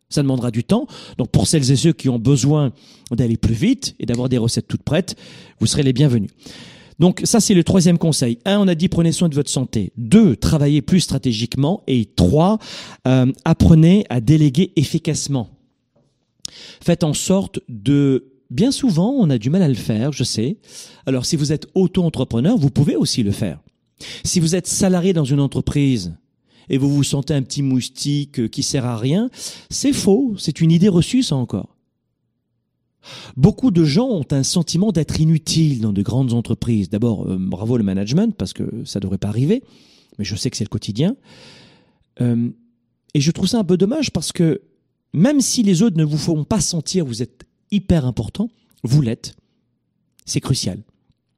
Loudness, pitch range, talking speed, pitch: -18 LUFS, 125-180 Hz, 190 wpm, 145 Hz